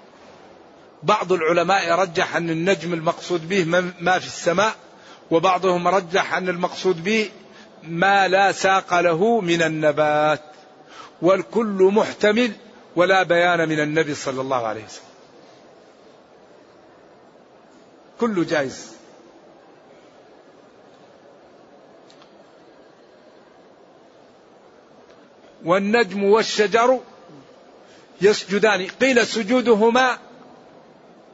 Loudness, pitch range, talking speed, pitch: -19 LUFS, 170-215 Hz, 75 wpm, 190 Hz